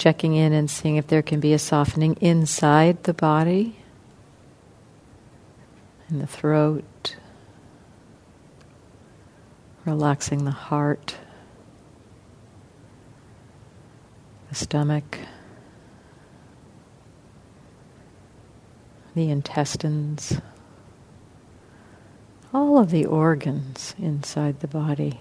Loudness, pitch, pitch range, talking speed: -22 LUFS, 150 Hz, 125-155 Hz, 70 wpm